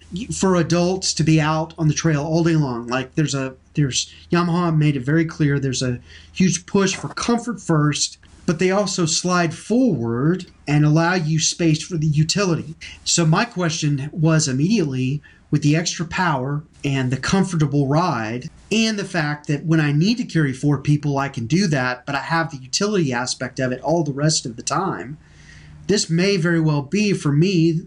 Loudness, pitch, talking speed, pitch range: -20 LUFS, 155 Hz, 190 wpm, 145-175 Hz